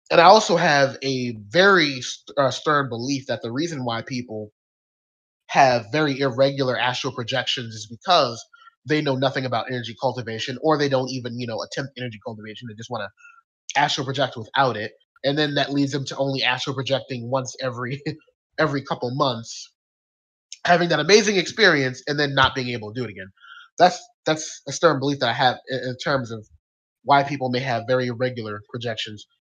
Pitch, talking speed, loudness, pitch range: 130 Hz, 185 wpm, -22 LUFS, 120-145 Hz